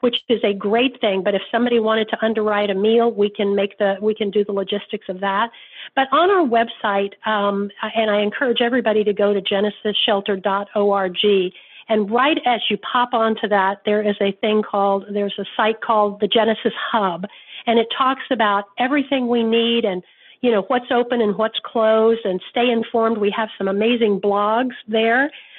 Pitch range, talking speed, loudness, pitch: 205-235 Hz, 190 wpm, -19 LUFS, 220 Hz